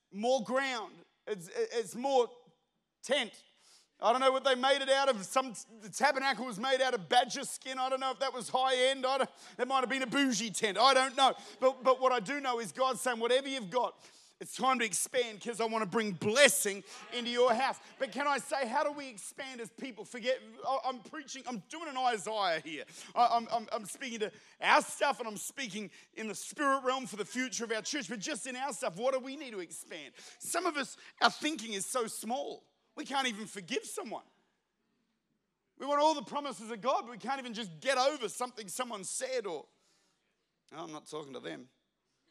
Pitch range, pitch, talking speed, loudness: 225-270 Hz, 255 Hz, 220 wpm, -32 LUFS